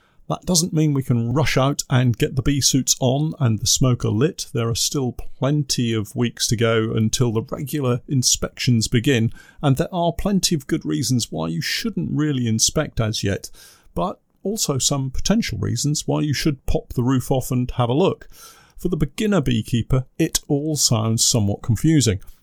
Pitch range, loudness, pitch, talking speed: 115-150 Hz, -20 LUFS, 130 Hz, 185 wpm